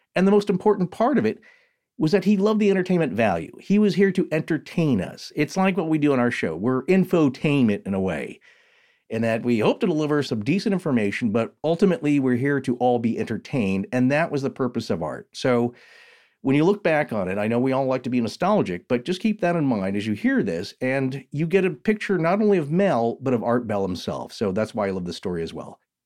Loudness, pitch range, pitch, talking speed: -23 LUFS, 120-185 Hz, 140 Hz, 240 wpm